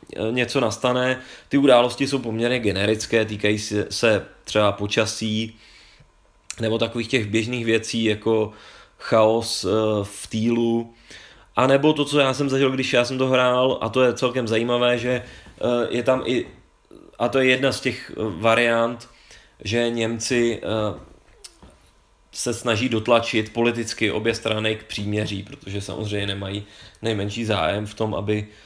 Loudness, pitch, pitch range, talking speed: -22 LUFS, 115 Hz, 105-120 Hz, 140 wpm